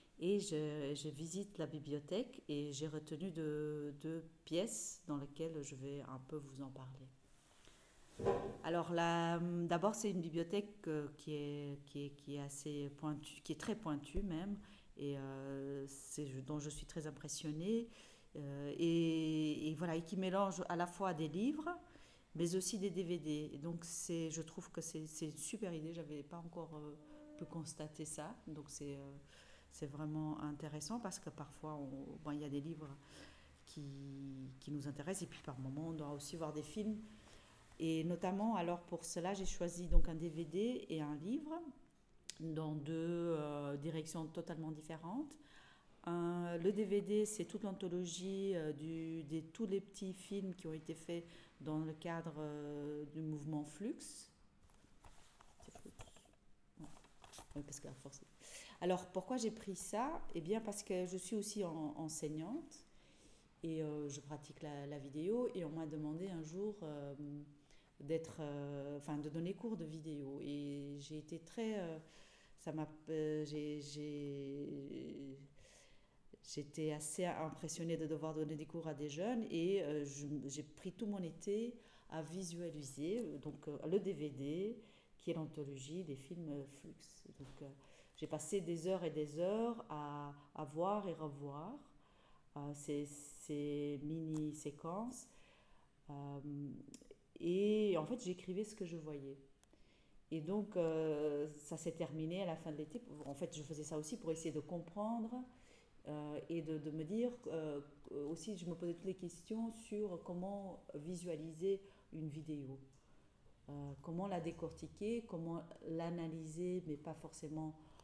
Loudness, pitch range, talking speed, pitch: -44 LUFS, 150-180 Hz, 160 wpm, 160 Hz